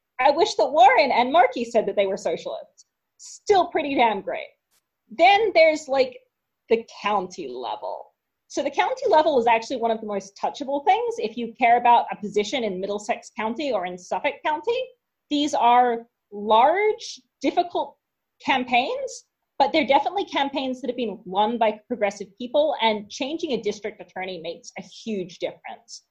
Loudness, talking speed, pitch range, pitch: -22 LUFS, 165 wpm, 215-320 Hz, 250 Hz